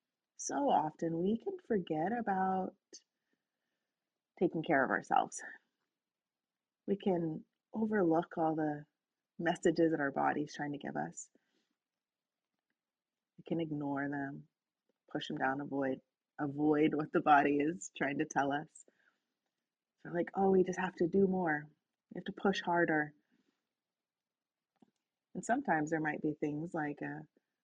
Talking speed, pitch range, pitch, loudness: 135 wpm, 150-190 Hz, 165 Hz, -35 LUFS